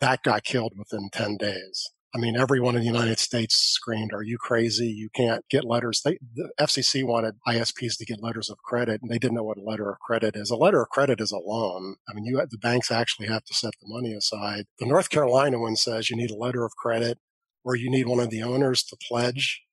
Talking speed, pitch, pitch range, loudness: 245 wpm, 115 Hz, 110-125 Hz, -25 LUFS